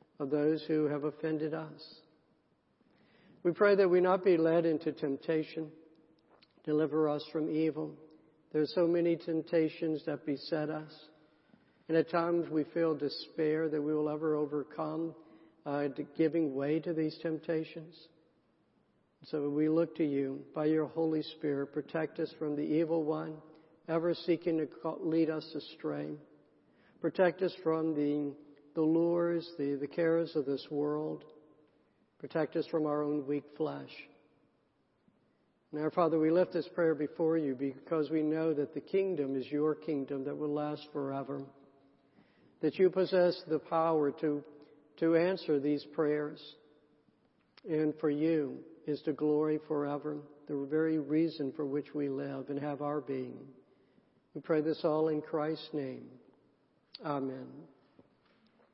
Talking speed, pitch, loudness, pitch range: 145 wpm, 155 Hz, -33 LUFS, 150-160 Hz